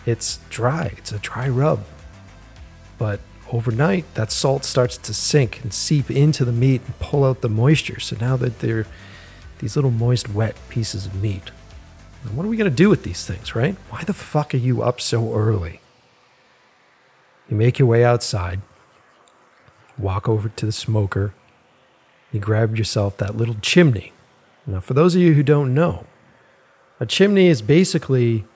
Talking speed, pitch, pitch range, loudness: 170 wpm, 115 Hz, 105-130 Hz, -20 LUFS